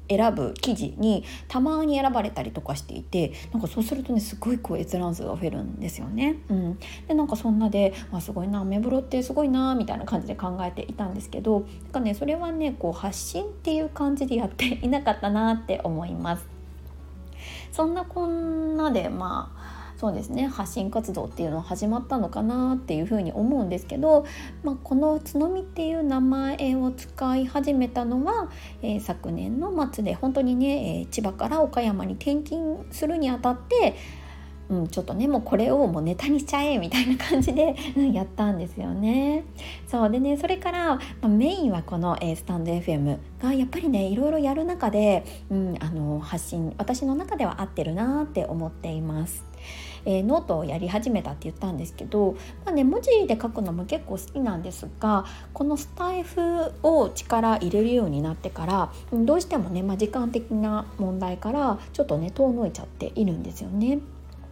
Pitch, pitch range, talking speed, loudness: 235 Hz, 190-285 Hz, 380 characters per minute, -26 LUFS